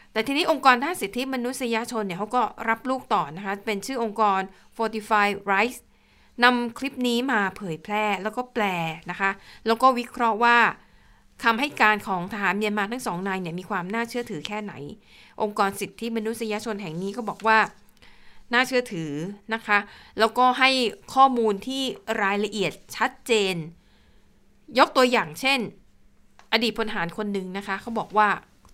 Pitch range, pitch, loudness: 200-240 Hz, 220 Hz, -24 LUFS